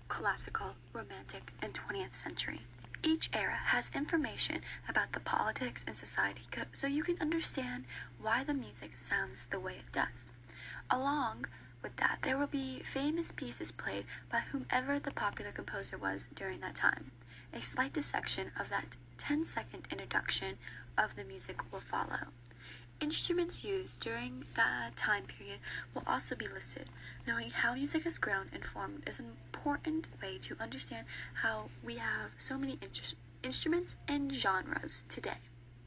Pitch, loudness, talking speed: 270 Hz, -38 LUFS, 150 wpm